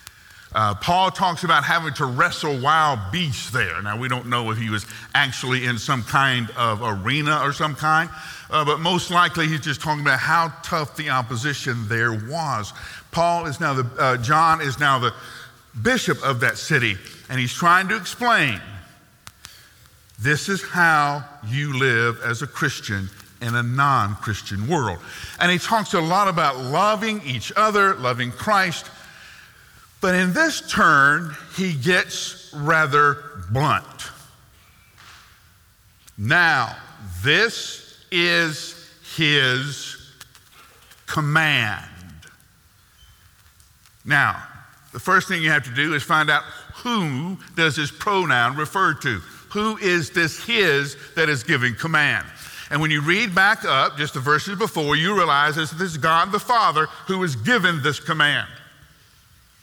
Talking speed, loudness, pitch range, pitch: 145 wpm, -20 LUFS, 120-170 Hz, 145 Hz